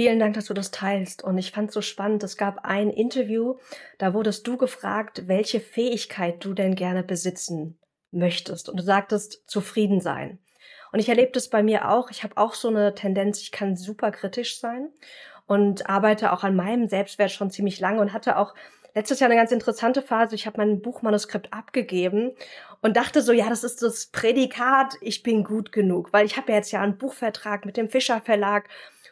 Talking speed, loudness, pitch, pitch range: 200 wpm, -24 LUFS, 215 Hz, 200-235 Hz